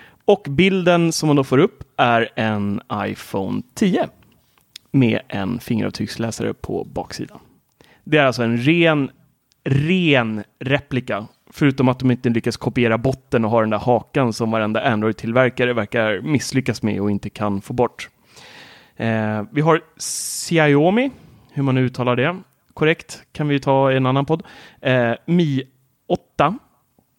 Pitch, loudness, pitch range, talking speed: 130 Hz, -19 LUFS, 115-145 Hz, 140 wpm